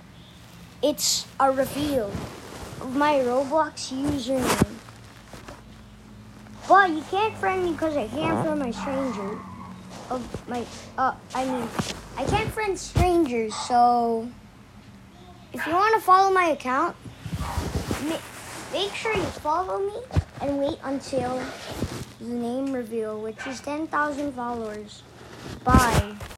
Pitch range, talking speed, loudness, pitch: 225-310 Hz, 115 wpm, -25 LUFS, 265 Hz